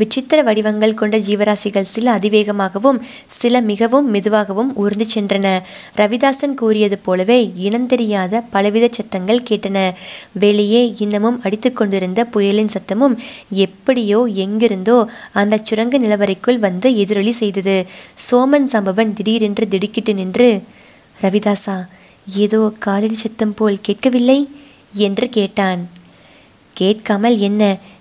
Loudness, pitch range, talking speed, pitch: -15 LUFS, 200-235 Hz, 105 wpm, 215 Hz